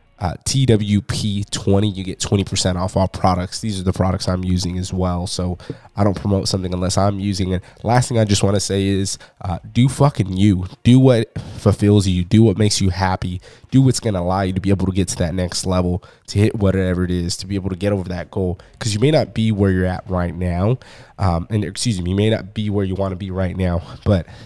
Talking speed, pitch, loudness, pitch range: 250 wpm, 100 Hz, -19 LUFS, 95-110 Hz